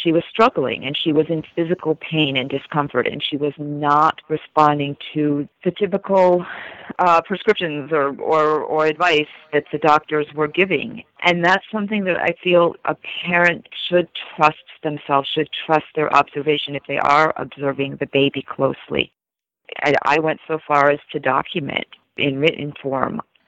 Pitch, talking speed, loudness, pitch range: 155 Hz, 160 wpm, -19 LUFS, 145-170 Hz